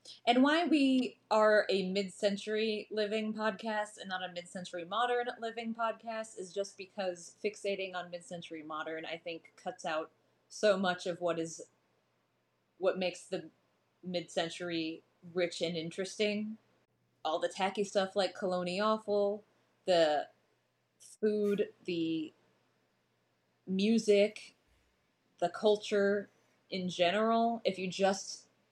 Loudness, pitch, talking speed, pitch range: -34 LUFS, 195 Hz, 115 wpm, 175-215 Hz